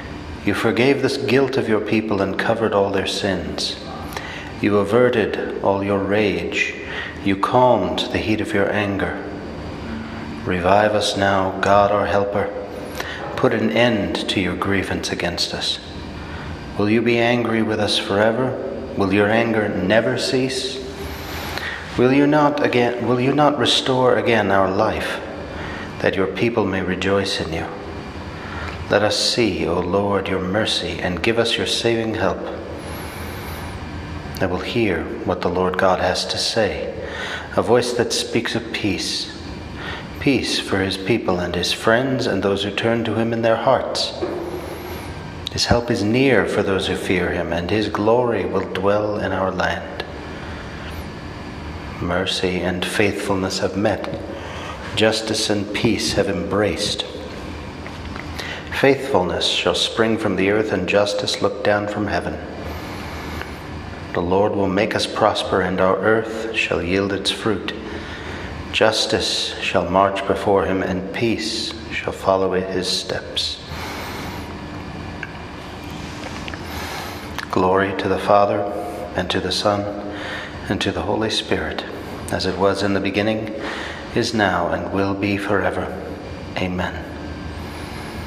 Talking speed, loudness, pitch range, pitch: 135 wpm, -20 LUFS, 90-105 Hz, 95 Hz